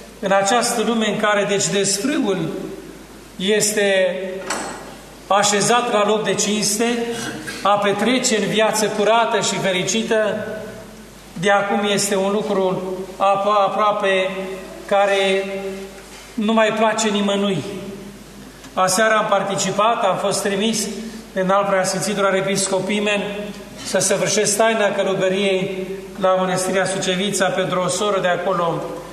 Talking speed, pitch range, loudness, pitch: 110 wpm, 190-210 Hz, -18 LUFS, 200 Hz